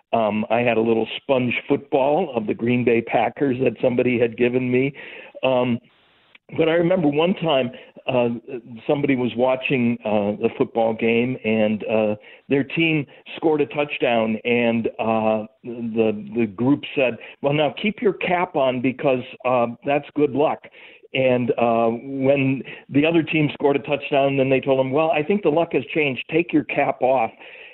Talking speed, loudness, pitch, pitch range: 175 wpm, -21 LUFS, 130 Hz, 115-145 Hz